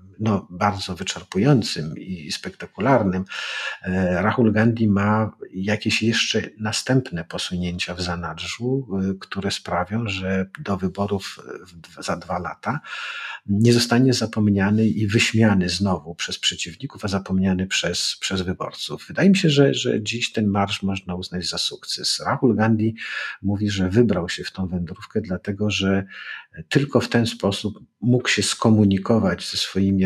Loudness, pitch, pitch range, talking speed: -22 LUFS, 100 Hz, 95-110 Hz, 135 wpm